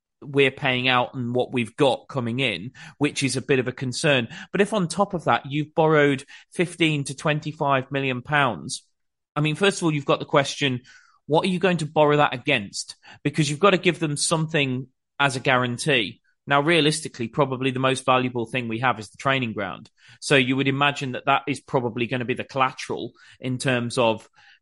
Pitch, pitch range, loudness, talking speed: 140 Hz, 130-150 Hz, -23 LUFS, 205 wpm